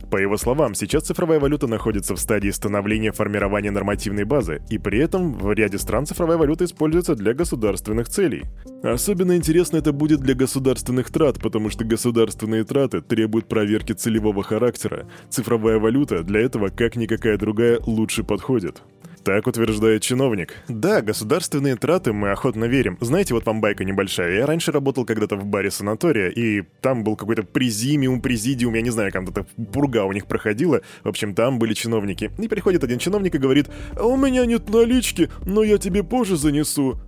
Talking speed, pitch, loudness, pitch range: 170 wpm, 115 Hz, -21 LUFS, 110-150 Hz